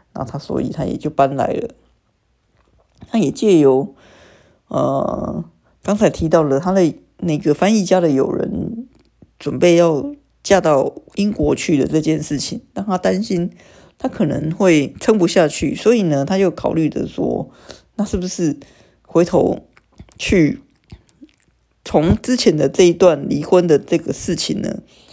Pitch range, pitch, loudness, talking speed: 155-205 Hz, 175 Hz, -17 LUFS, 205 characters per minute